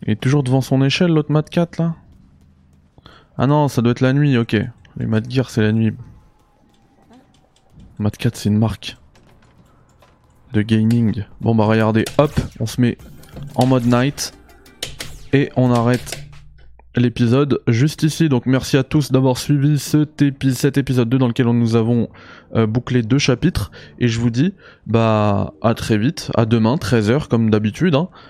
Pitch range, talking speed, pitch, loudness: 110-140 Hz, 170 wpm, 125 Hz, -17 LUFS